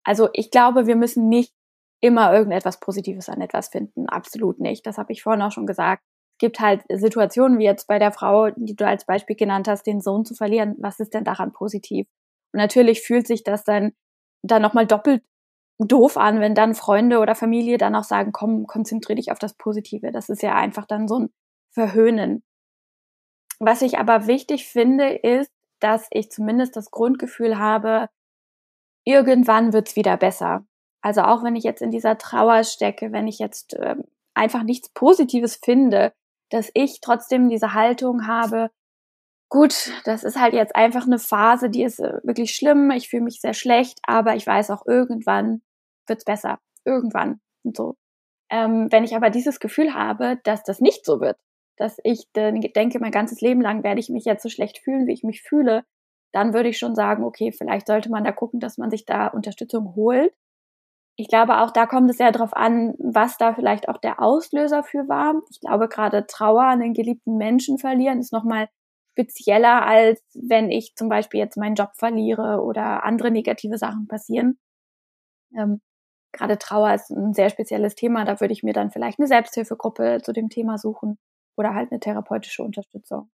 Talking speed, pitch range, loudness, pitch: 190 wpm, 215-240 Hz, -20 LUFS, 225 Hz